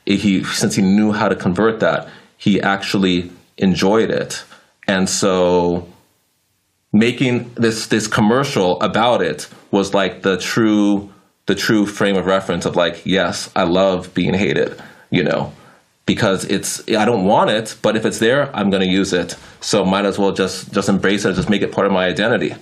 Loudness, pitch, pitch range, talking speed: -17 LUFS, 100 Hz, 95-100 Hz, 180 wpm